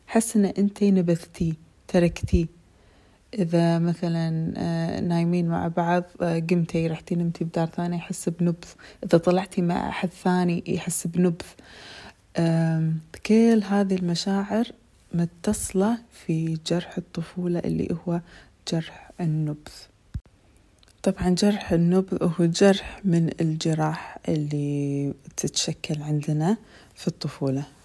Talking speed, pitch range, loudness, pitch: 100 wpm, 160-185 Hz, -25 LUFS, 170 Hz